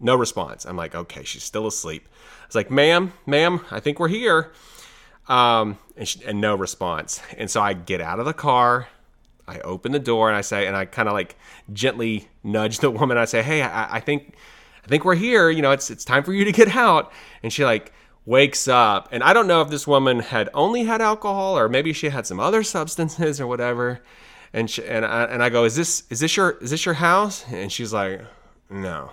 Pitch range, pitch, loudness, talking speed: 110-160 Hz, 125 Hz, -20 LUFS, 230 wpm